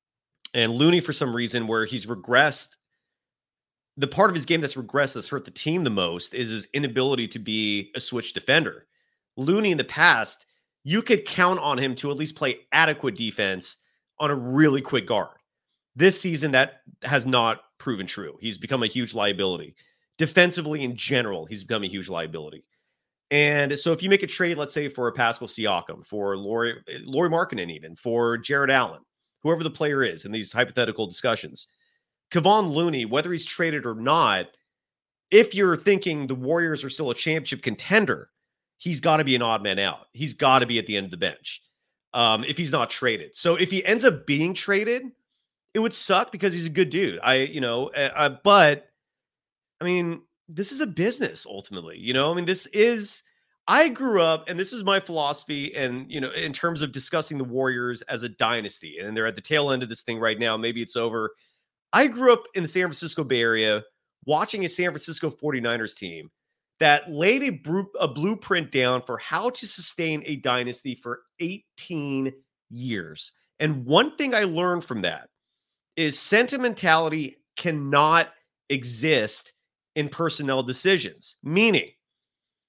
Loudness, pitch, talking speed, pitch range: -23 LUFS, 145 Hz, 180 wpm, 120-175 Hz